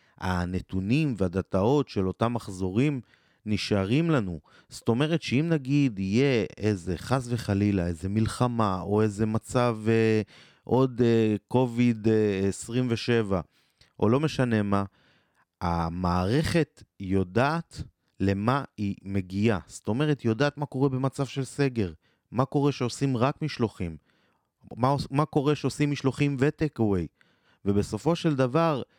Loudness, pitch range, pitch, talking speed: -27 LUFS, 100-140 Hz, 115 Hz, 120 wpm